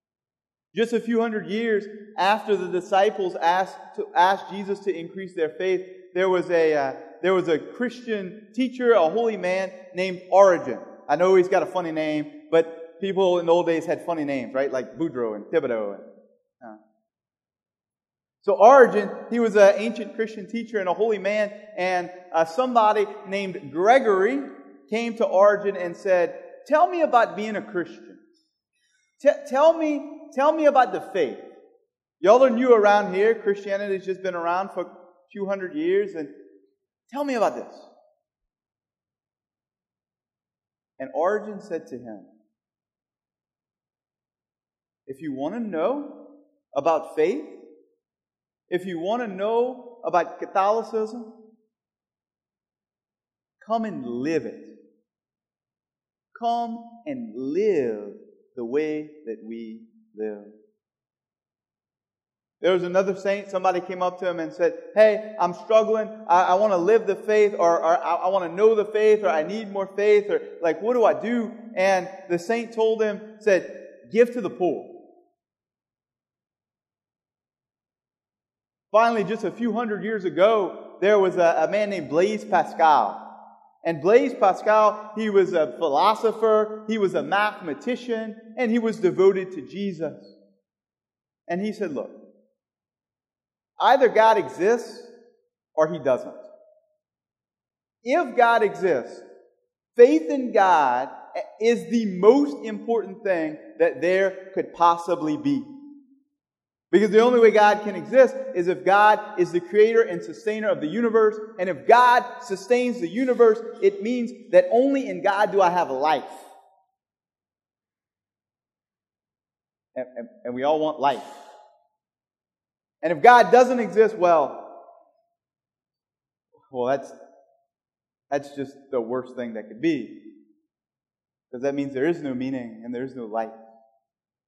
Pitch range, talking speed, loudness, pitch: 180-250 Hz, 140 wpm, -22 LUFS, 210 Hz